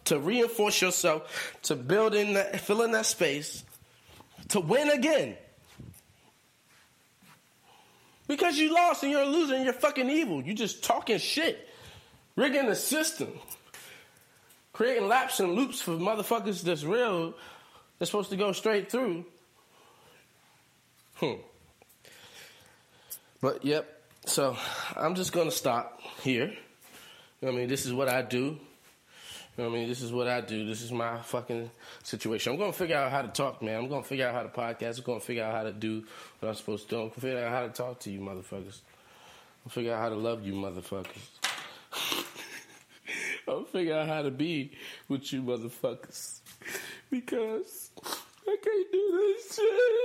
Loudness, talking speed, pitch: -30 LUFS, 170 wpm, 160 Hz